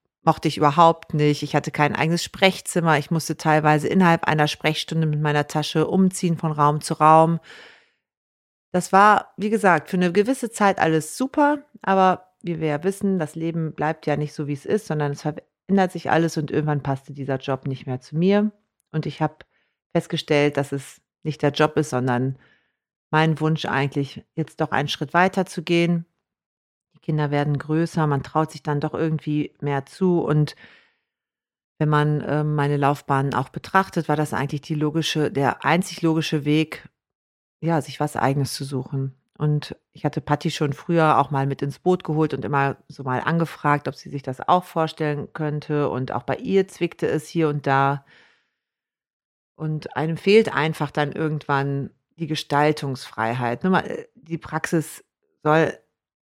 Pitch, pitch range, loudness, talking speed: 155 Hz, 145-170 Hz, -22 LUFS, 170 wpm